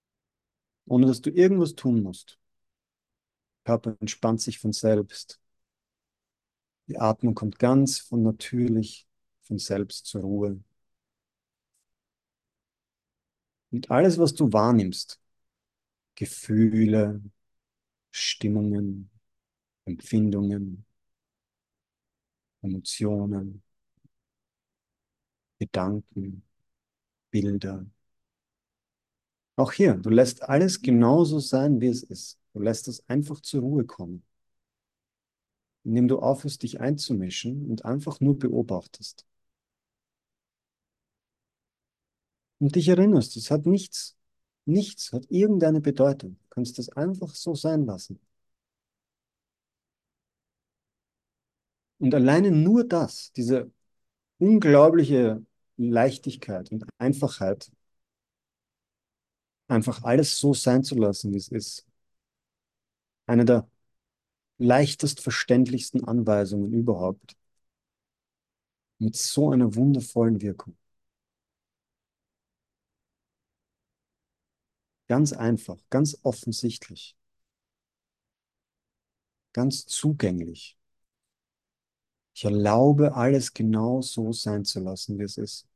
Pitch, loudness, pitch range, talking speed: 115 Hz, -24 LUFS, 105-135 Hz, 85 wpm